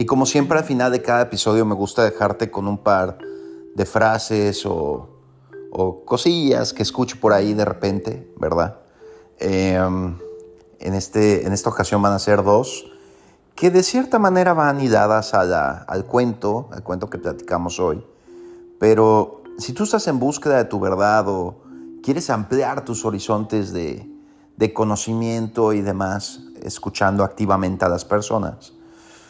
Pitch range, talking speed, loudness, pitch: 95-120 Hz, 155 wpm, -19 LUFS, 105 Hz